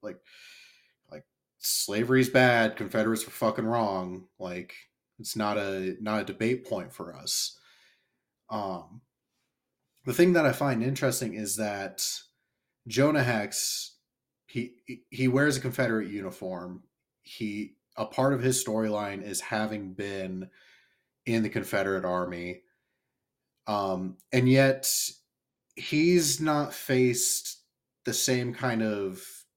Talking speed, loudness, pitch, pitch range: 120 wpm, -28 LUFS, 115 Hz, 100-130 Hz